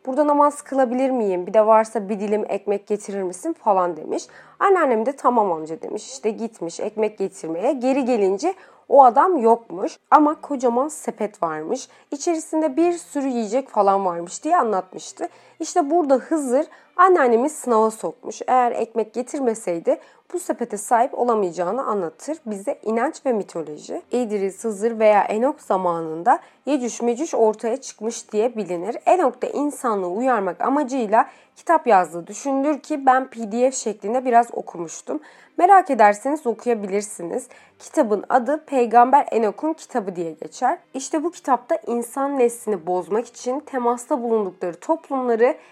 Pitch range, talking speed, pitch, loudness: 210-280 Hz, 135 wpm, 240 Hz, -21 LUFS